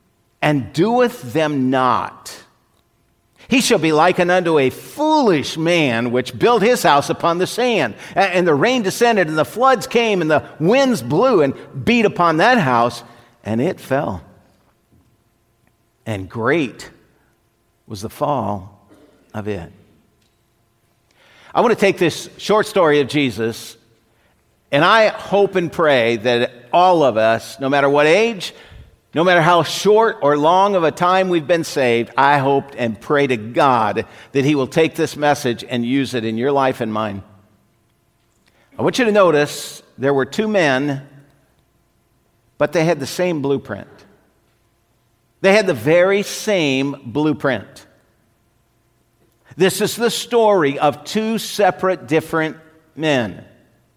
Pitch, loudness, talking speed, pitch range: 140 Hz, -16 LUFS, 145 wpm, 115-180 Hz